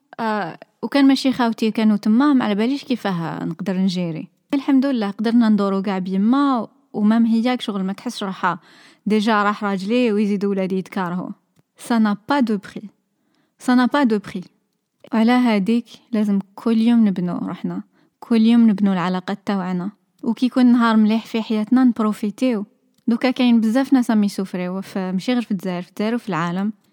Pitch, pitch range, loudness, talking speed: 215 Hz, 195-240 Hz, -19 LUFS, 150 wpm